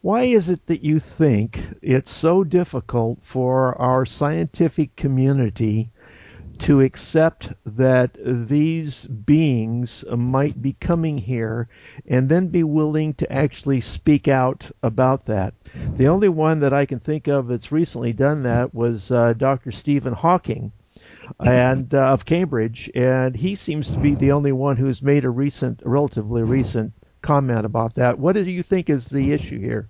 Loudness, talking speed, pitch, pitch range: -20 LUFS, 155 wpm, 135 Hz, 120-150 Hz